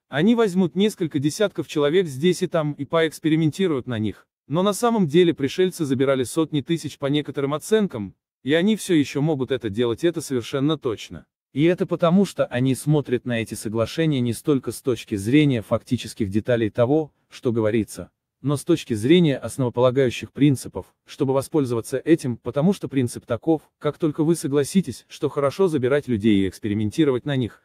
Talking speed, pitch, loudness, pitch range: 165 wpm, 140 Hz, -22 LUFS, 120-165 Hz